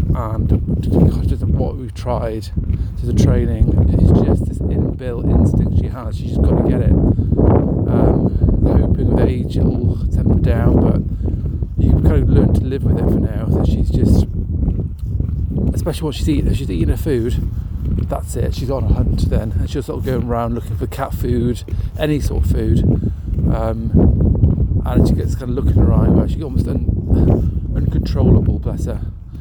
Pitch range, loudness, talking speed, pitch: 85-105 Hz, -17 LUFS, 180 wpm, 95 Hz